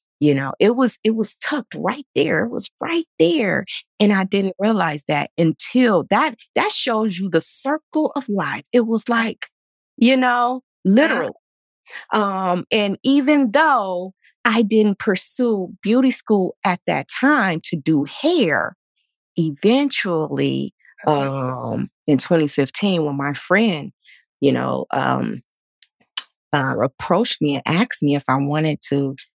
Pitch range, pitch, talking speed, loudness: 160-245 Hz, 200 Hz, 140 wpm, -19 LUFS